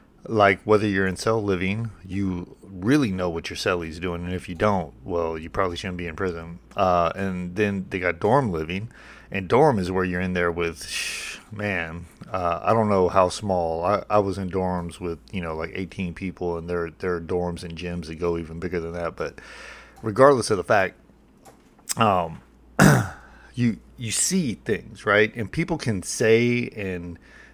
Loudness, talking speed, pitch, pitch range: -24 LUFS, 185 wpm, 90 Hz, 85-105 Hz